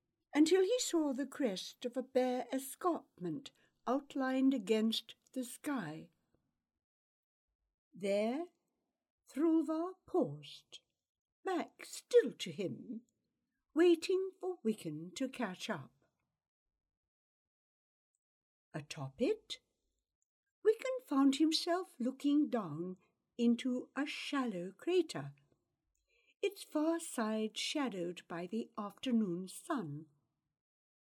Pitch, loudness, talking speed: 245 Hz, -37 LUFS, 85 wpm